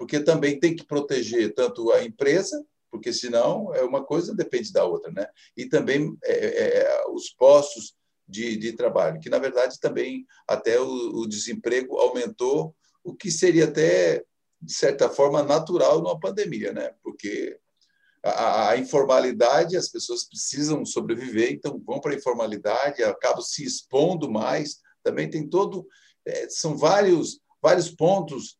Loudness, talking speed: -23 LUFS, 135 wpm